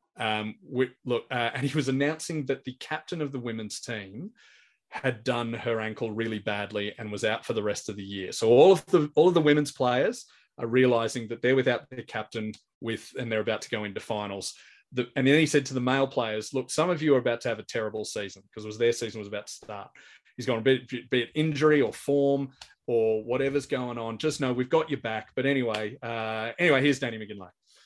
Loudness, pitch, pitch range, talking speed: -27 LUFS, 125 Hz, 110-140 Hz, 235 wpm